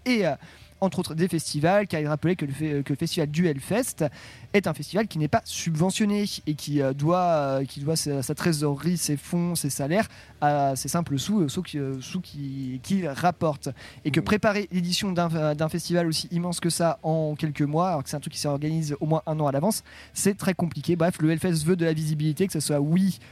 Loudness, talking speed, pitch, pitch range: -26 LUFS, 230 wpm, 160 Hz, 145-180 Hz